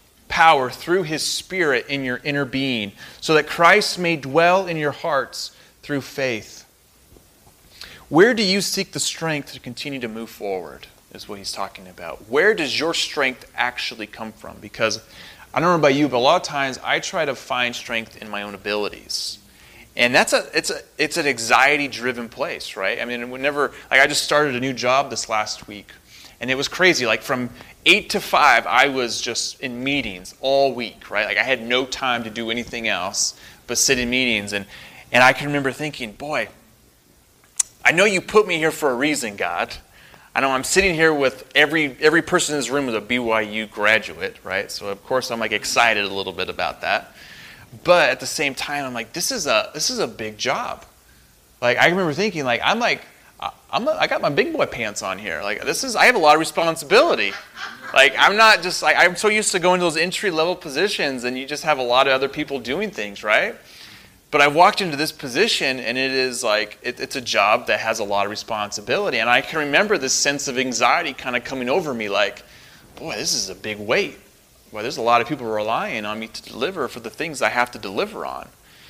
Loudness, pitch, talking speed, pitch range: -19 LUFS, 135 Hz, 215 wpm, 115-155 Hz